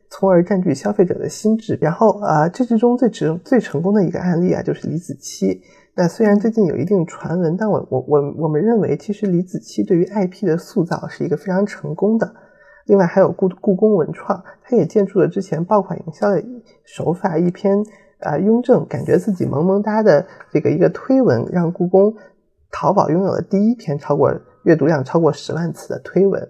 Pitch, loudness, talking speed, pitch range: 190 Hz, -17 LUFS, 315 characters per minute, 165-210 Hz